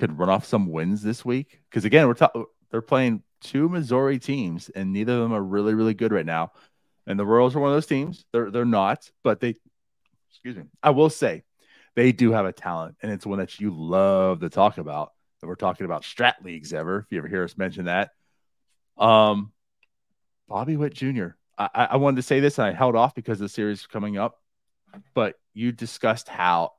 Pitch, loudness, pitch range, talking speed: 115 Hz, -23 LUFS, 100-130 Hz, 215 wpm